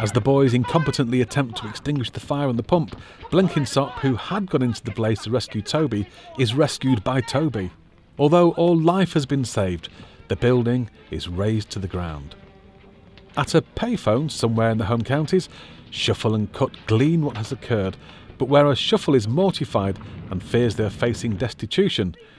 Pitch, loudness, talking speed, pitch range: 120 Hz, -22 LUFS, 175 wpm, 105-145 Hz